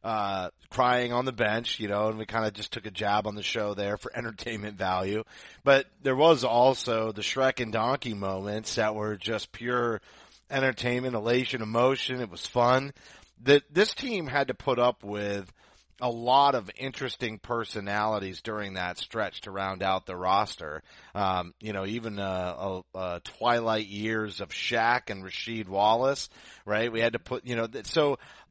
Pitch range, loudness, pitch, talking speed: 100-125 Hz, -28 LUFS, 110 Hz, 175 wpm